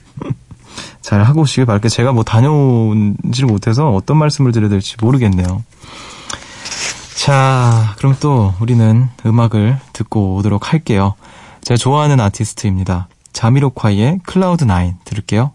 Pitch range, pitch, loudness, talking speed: 105-135 Hz, 115 Hz, -13 LUFS, 310 characters per minute